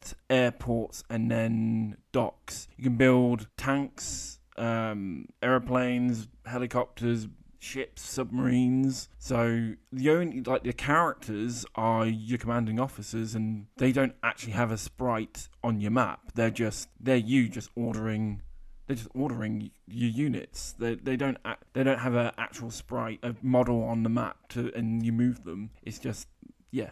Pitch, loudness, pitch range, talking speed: 120 Hz, -29 LUFS, 110-125 Hz, 150 wpm